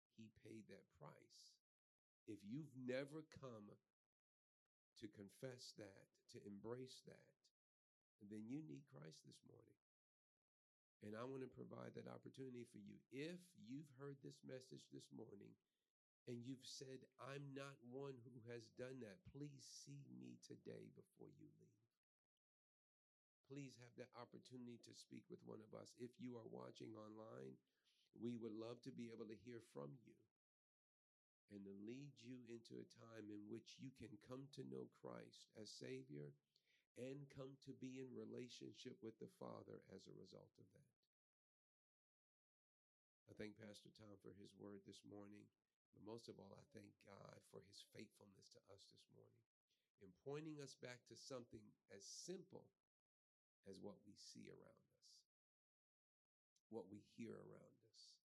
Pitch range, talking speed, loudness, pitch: 100-130 Hz, 155 wpm, -59 LUFS, 115 Hz